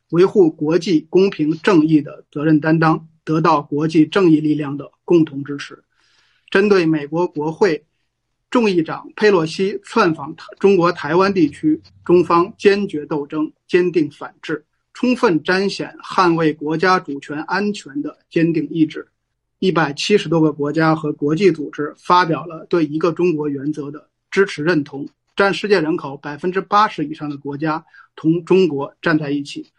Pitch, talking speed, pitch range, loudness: 160 Hz, 250 characters per minute, 150-185 Hz, -17 LUFS